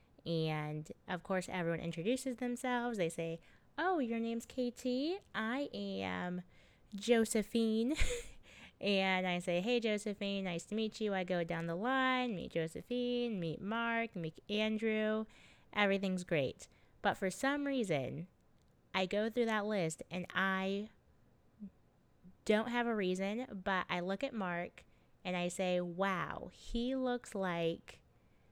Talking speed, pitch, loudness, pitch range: 135 wpm, 200 Hz, -37 LUFS, 180-235 Hz